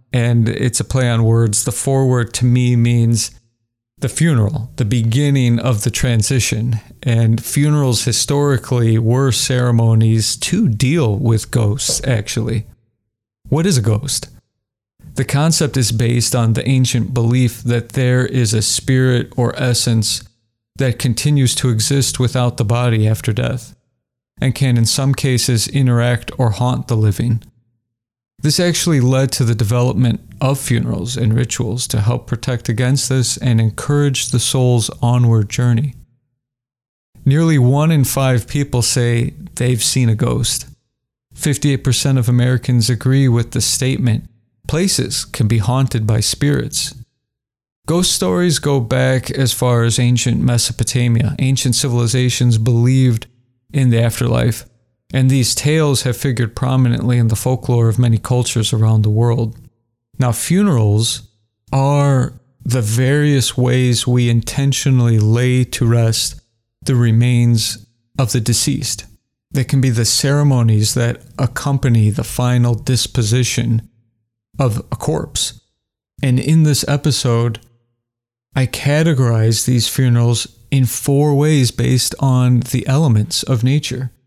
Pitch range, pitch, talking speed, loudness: 115-130 Hz, 125 Hz, 130 wpm, -15 LUFS